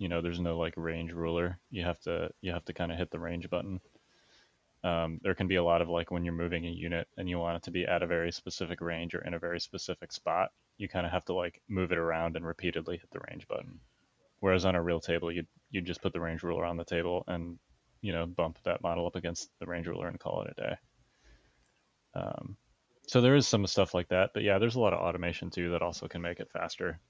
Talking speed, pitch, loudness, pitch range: 260 wpm, 85 Hz, -33 LUFS, 85-90 Hz